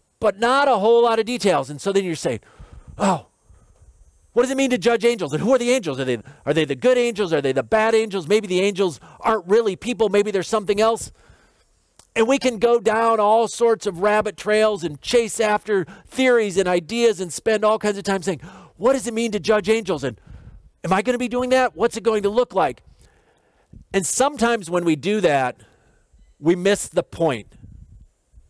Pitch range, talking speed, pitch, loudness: 180-230 Hz, 215 wpm, 210 Hz, -20 LUFS